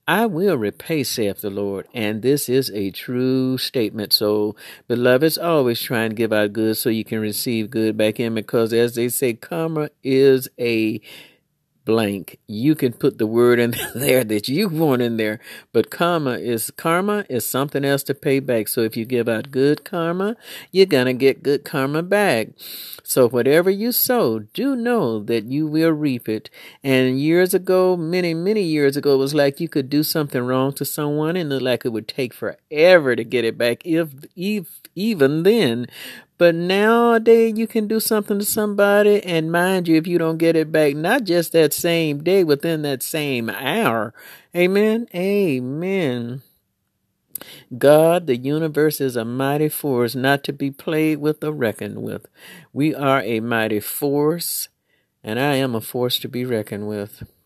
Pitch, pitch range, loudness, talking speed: 140 Hz, 120-170 Hz, -19 LUFS, 180 wpm